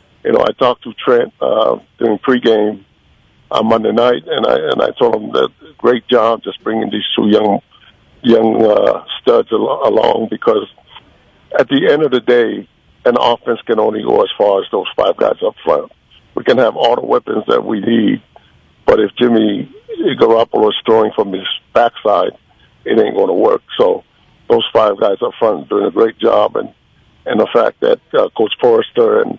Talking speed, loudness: 190 wpm, -13 LUFS